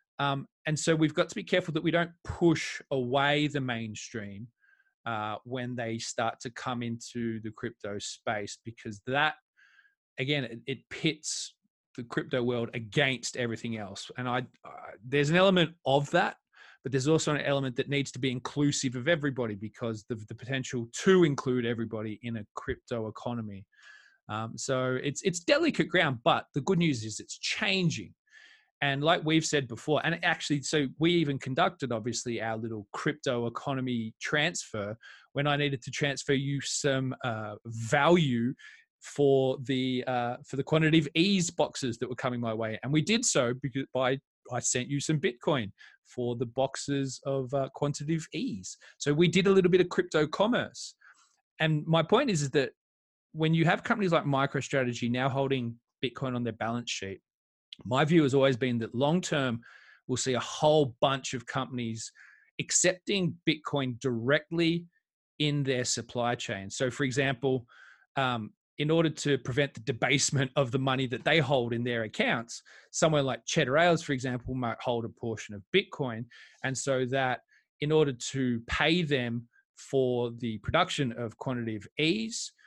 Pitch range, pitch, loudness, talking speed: 120-155 Hz, 135 Hz, -29 LUFS, 170 wpm